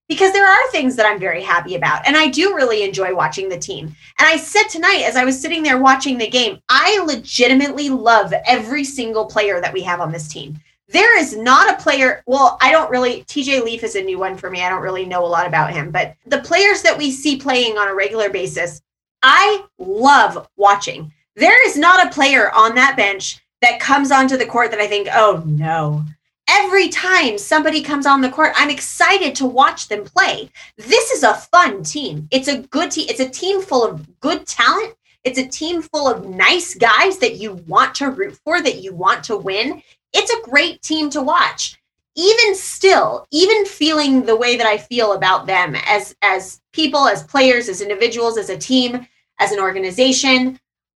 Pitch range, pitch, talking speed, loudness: 205-330 Hz, 260 Hz, 205 wpm, -14 LUFS